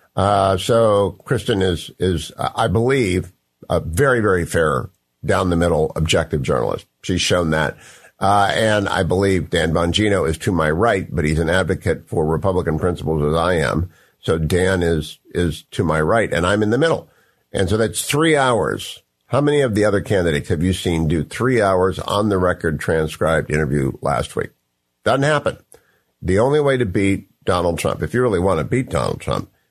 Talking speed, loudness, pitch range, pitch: 190 wpm, -19 LUFS, 80-105 Hz, 95 Hz